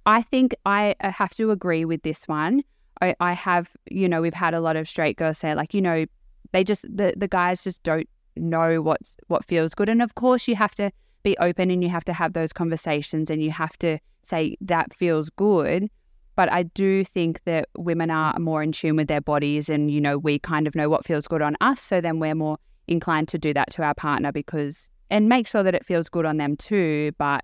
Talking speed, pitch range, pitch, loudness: 235 wpm, 155-190 Hz, 165 Hz, -23 LUFS